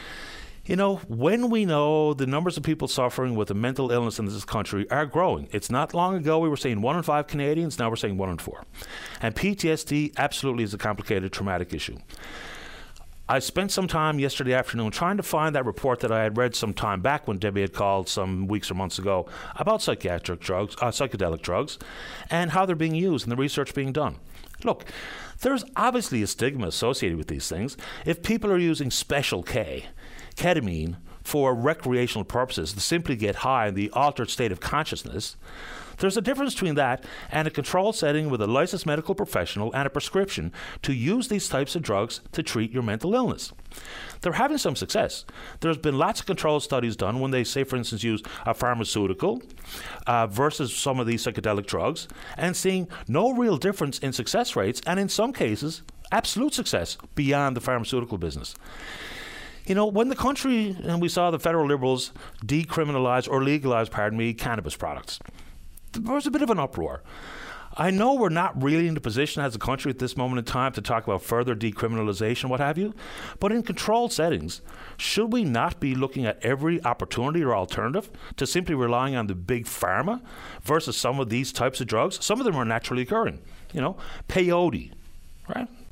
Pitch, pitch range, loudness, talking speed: 135 Hz, 115-170 Hz, -26 LUFS, 190 wpm